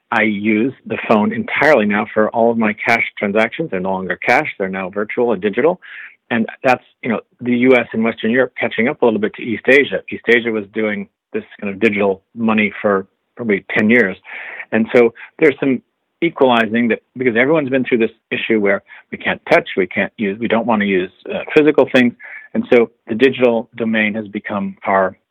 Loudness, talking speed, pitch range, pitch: -16 LUFS, 205 wpm, 105-120 Hz, 110 Hz